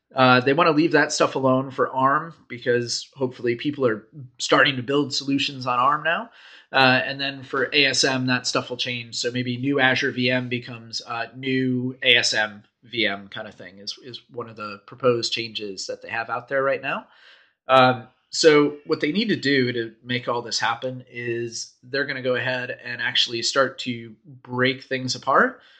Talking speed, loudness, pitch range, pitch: 190 wpm, -22 LUFS, 120-135 Hz, 125 Hz